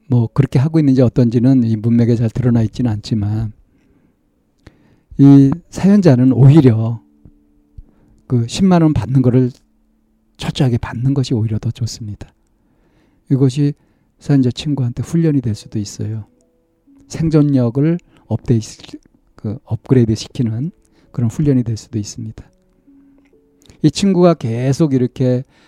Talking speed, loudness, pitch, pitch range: 265 characters per minute, -15 LUFS, 125 Hz, 110-145 Hz